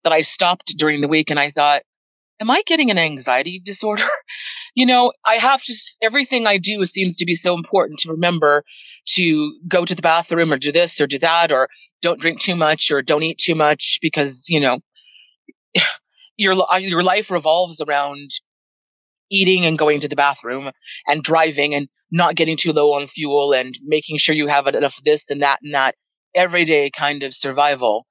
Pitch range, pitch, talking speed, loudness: 145-180 Hz, 160 Hz, 190 wpm, -17 LUFS